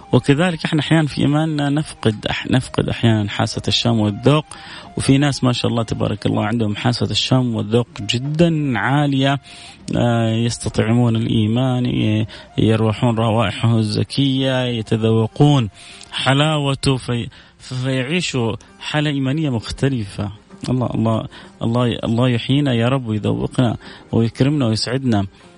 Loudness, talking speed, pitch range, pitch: -18 LUFS, 115 wpm, 110-135 Hz, 120 Hz